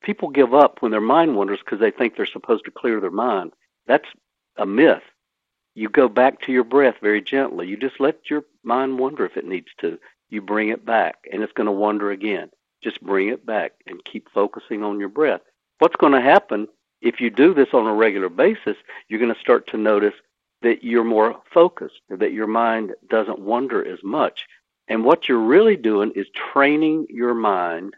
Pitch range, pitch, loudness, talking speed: 105-140 Hz, 120 Hz, -19 LUFS, 205 wpm